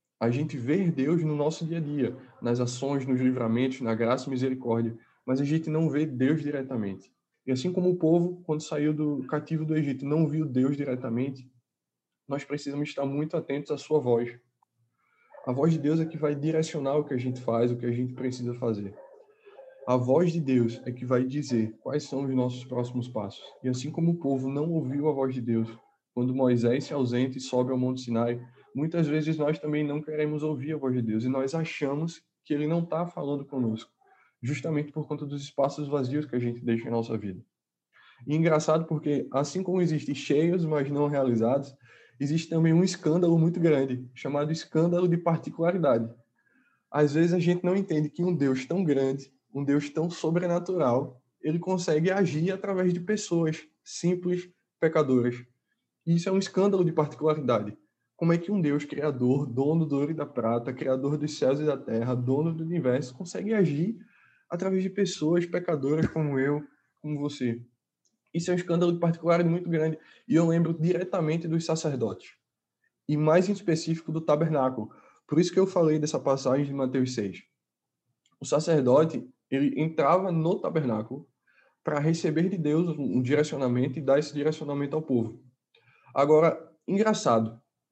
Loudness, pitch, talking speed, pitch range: -27 LUFS, 150 Hz, 180 wpm, 130-165 Hz